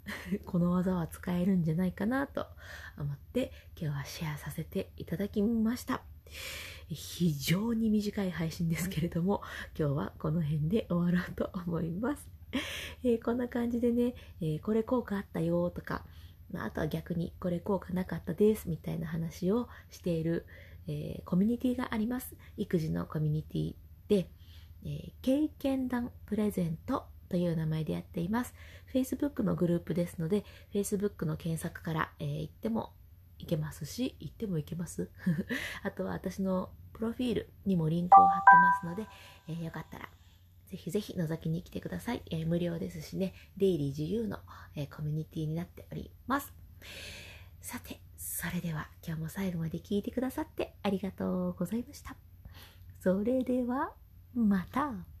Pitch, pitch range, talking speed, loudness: 175 Hz, 155-205 Hz, 345 characters per minute, -33 LUFS